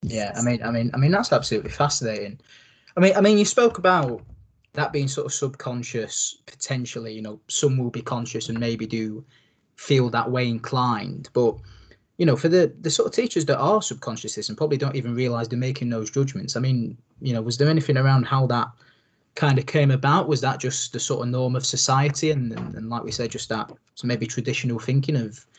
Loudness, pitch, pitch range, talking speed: -23 LUFS, 125 Hz, 115-145 Hz, 215 wpm